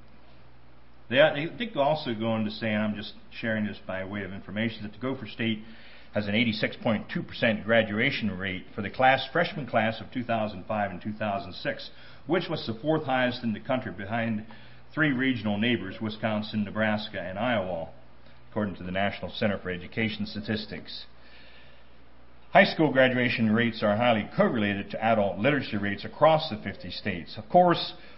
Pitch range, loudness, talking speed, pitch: 100-125 Hz, -27 LUFS, 160 wpm, 110 Hz